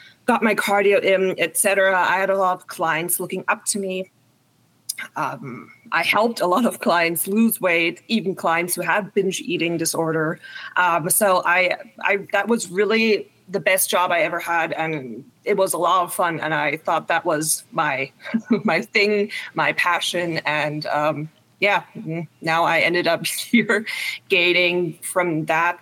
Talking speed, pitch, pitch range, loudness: 170 wpm, 180 Hz, 165-200 Hz, -20 LUFS